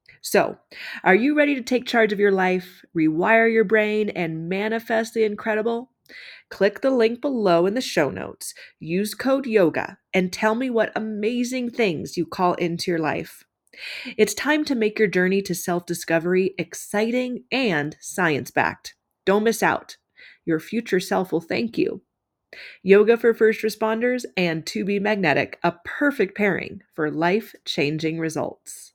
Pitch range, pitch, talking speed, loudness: 180-235 Hz, 215 Hz, 150 wpm, -22 LUFS